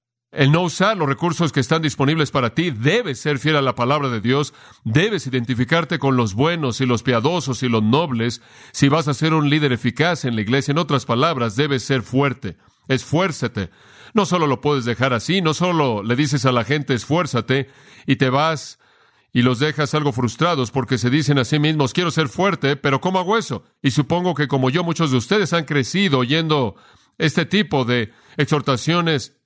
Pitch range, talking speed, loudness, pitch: 130-160 Hz, 195 wpm, -19 LUFS, 145 Hz